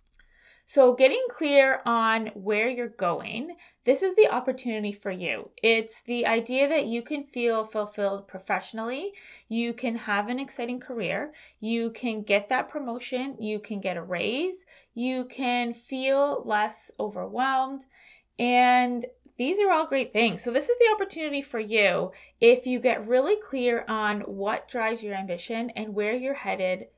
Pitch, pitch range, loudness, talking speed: 240 Hz, 220-270 Hz, -26 LUFS, 155 wpm